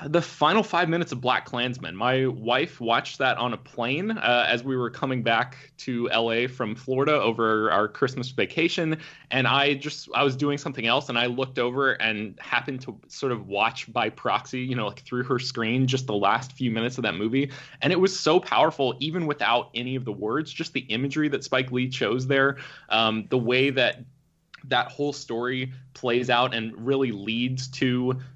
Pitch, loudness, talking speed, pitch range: 130 Hz, -25 LUFS, 200 wpm, 120-140 Hz